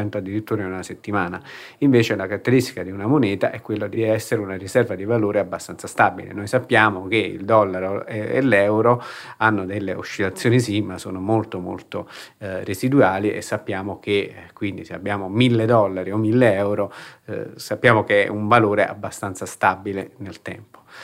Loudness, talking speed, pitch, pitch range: -21 LUFS, 170 wpm, 105 Hz, 95-115 Hz